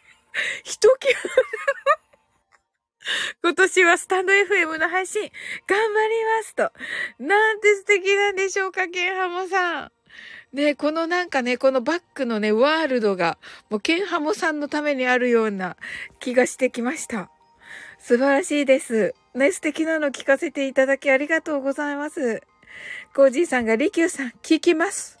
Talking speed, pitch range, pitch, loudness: 300 characters per minute, 270-385 Hz, 320 Hz, -21 LUFS